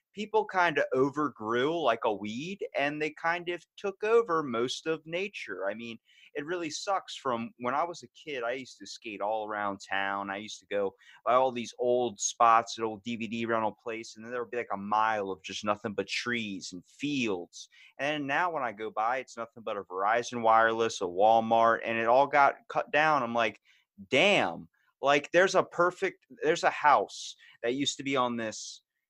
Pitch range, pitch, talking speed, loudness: 110-160 Hz, 120 Hz, 205 wpm, -29 LUFS